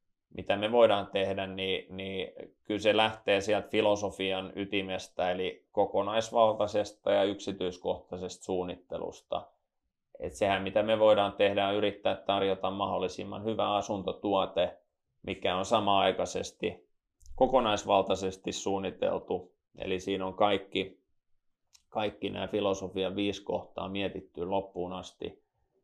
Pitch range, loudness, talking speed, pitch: 95-105 Hz, -31 LUFS, 105 wpm, 100 Hz